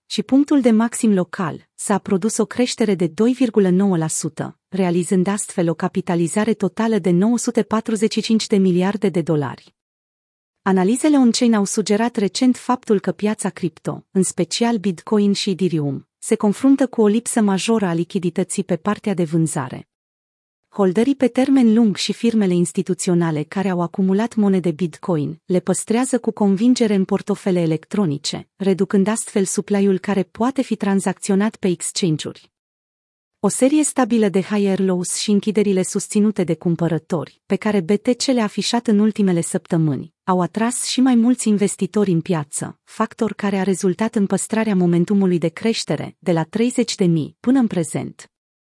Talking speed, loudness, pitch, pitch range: 145 wpm, -19 LUFS, 200 Hz, 180-220 Hz